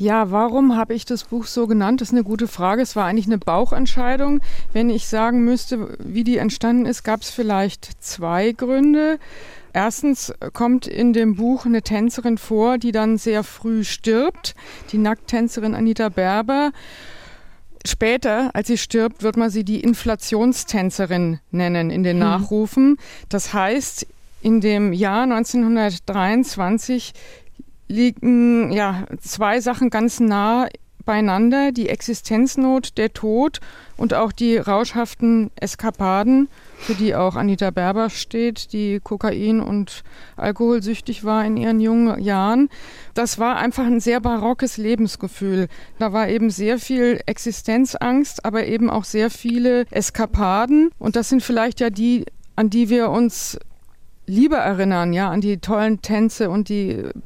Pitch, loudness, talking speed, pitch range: 225 Hz, -19 LUFS, 145 wpm, 210-240 Hz